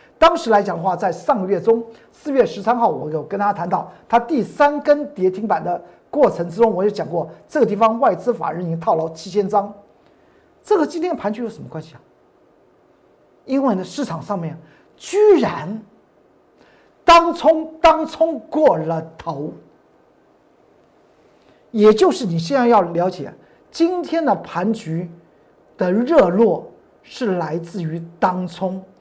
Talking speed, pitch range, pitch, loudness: 215 characters per minute, 175-285 Hz, 210 Hz, -18 LUFS